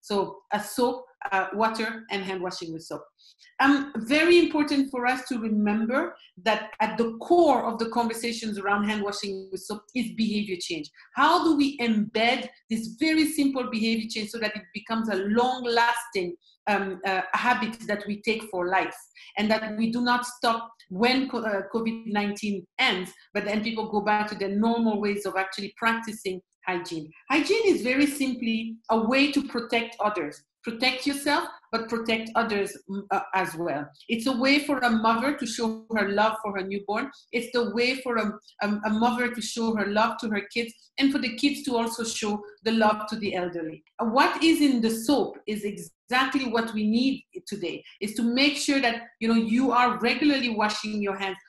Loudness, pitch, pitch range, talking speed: -26 LUFS, 225 Hz, 205-245 Hz, 185 wpm